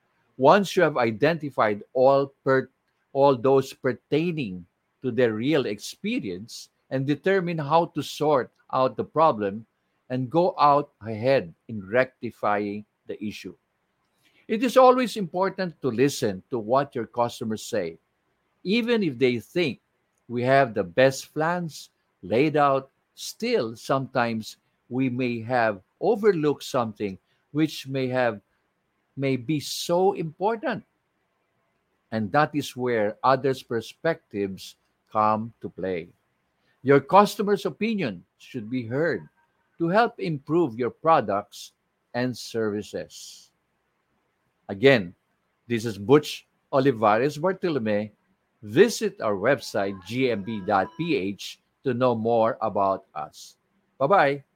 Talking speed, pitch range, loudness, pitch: 115 wpm, 115-160 Hz, -24 LUFS, 135 Hz